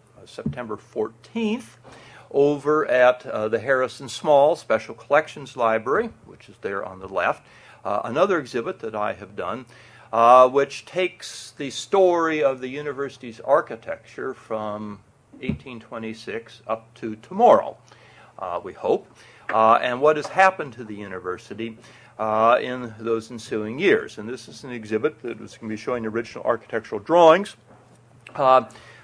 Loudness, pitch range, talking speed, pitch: -22 LUFS, 110-140 Hz, 145 wpm, 120 Hz